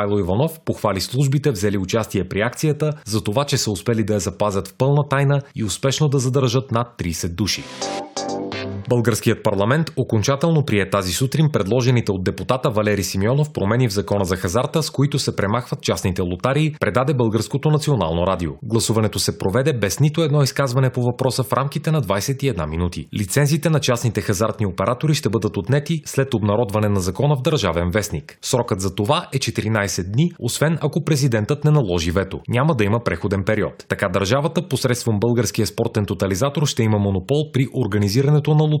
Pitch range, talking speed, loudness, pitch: 100-140 Hz, 170 wpm, -20 LUFS, 115 Hz